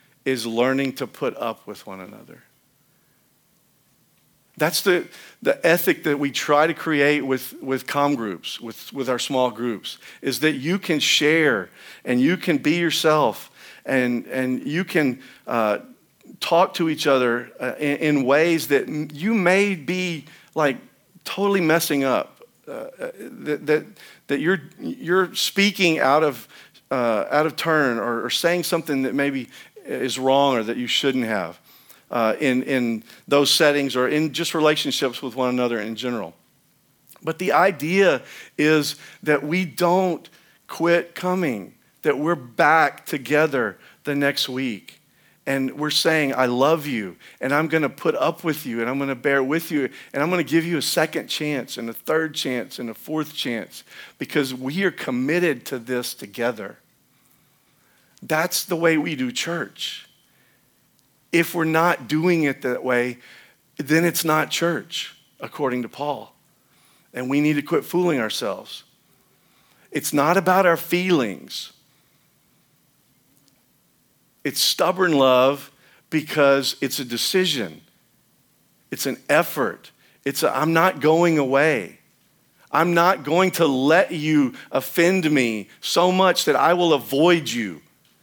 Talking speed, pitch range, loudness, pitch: 150 wpm, 130-170 Hz, -21 LUFS, 150 Hz